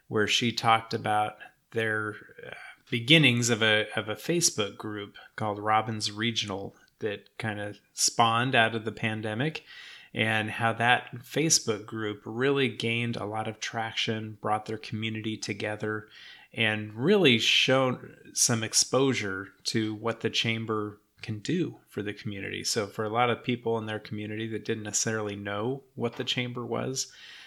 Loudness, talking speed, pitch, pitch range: -27 LUFS, 150 wpm, 110 Hz, 105-120 Hz